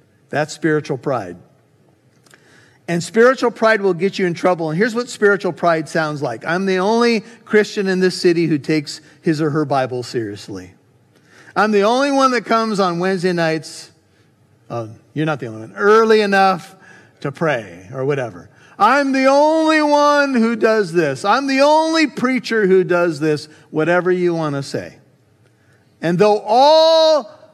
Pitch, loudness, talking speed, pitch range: 175 Hz, -16 LUFS, 165 wpm, 150-225 Hz